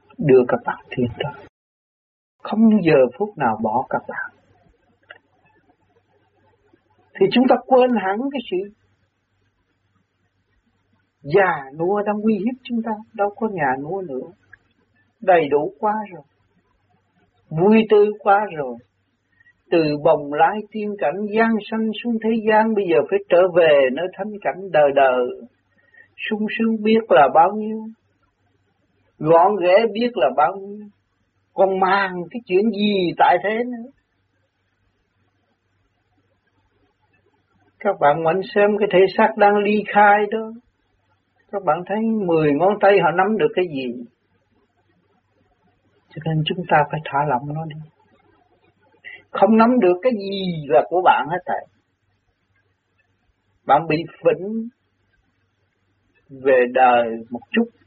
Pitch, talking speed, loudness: 170 Hz, 130 wpm, -18 LUFS